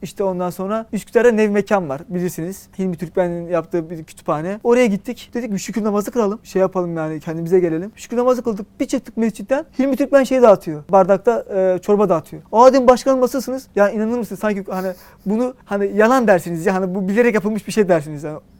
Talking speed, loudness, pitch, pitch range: 195 wpm, -18 LUFS, 200 Hz, 180-235 Hz